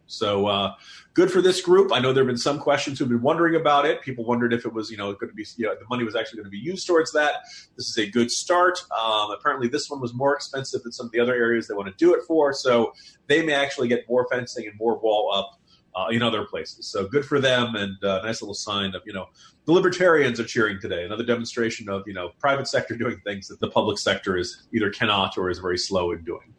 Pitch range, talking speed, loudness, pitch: 110-145 Hz, 270 wpm, -23 LUFS, 120 Hz